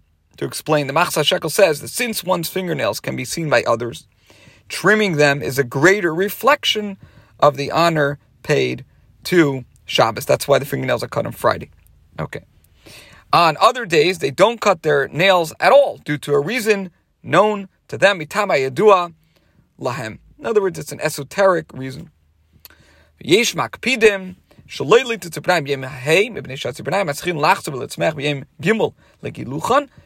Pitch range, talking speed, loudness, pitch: 140-195 Hz, 125 wpm, -18 LUFS, 165 Hz